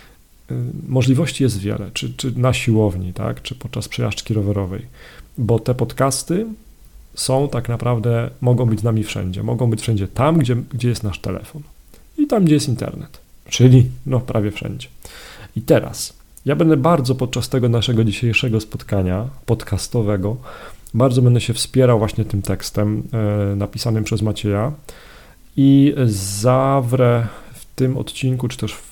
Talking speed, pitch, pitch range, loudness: 145 wpm, 120 Hz, 105-130 Hz, -18 LUFS